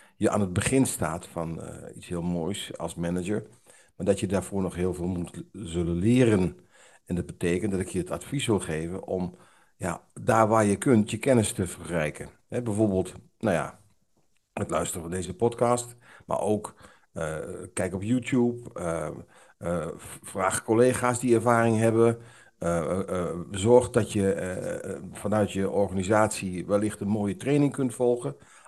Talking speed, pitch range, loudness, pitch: 170 wpm, 90-120 Hz, -27 LUFS, 100 Hz